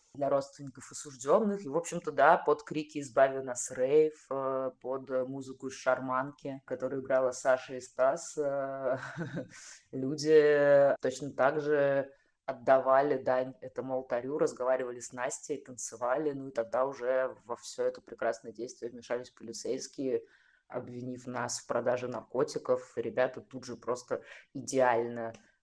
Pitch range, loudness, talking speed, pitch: 130-145 Hz, -31 LUFS, 125 wpm, 135 Hz